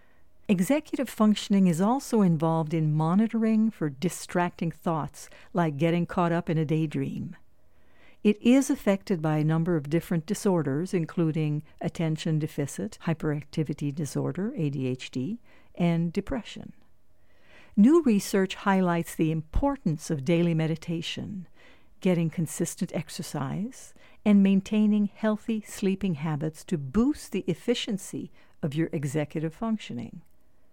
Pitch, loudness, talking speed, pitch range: 175 Hz, -27 LUFS, 115 wpm, 160-205 Hz